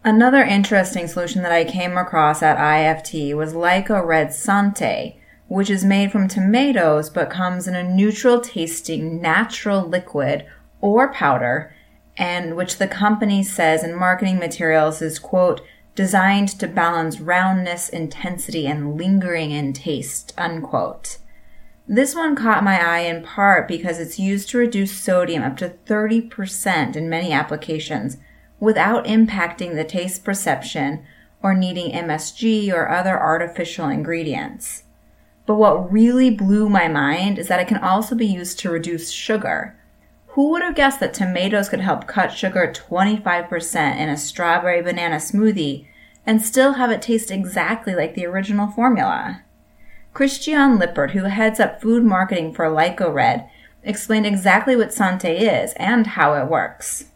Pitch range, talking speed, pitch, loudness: 165-215 Hz, 145 wpm, 185 Hz, -19 LUFS